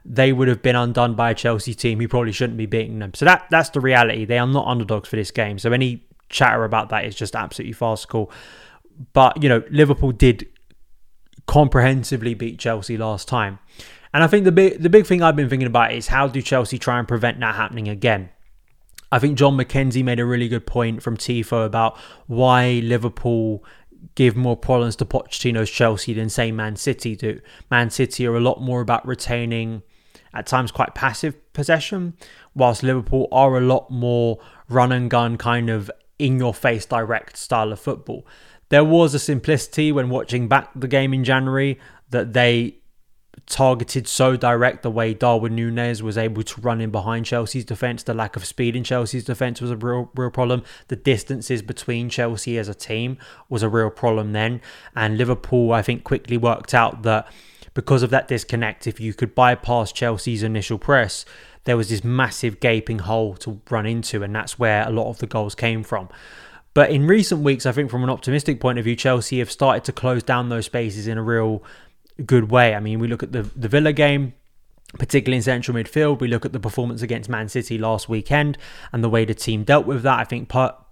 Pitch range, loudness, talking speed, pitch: 115-130 Hz, -20 LUFS, 200 wpm, 120 Hz